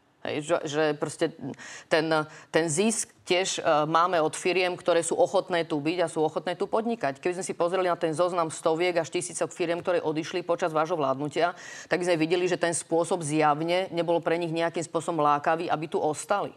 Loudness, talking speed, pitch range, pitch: -27 LUFS, 190 wpm, 160-180 Hz, 170 Hz